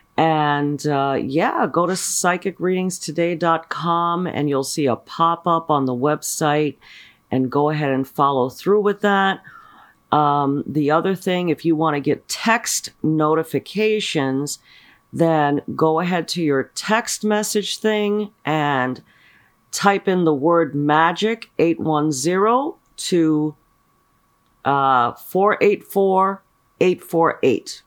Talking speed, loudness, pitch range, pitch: 115 wpm, -19 LUFS, 145-190 Hz, 160 Hz